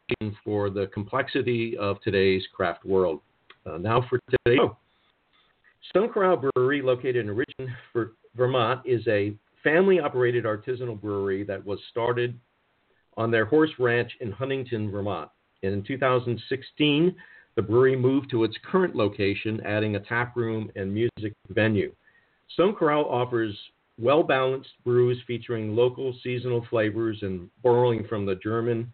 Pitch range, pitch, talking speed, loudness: 105-130 Hz, 120 Hz, 135 wpm, -26 LUFS